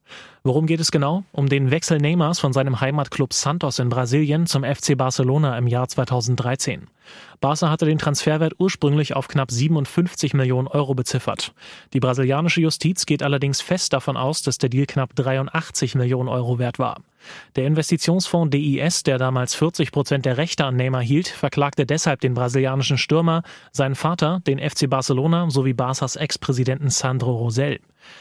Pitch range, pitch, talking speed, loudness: 130-155 Hz, 140 Hz, 160 wpm, -21 LUFS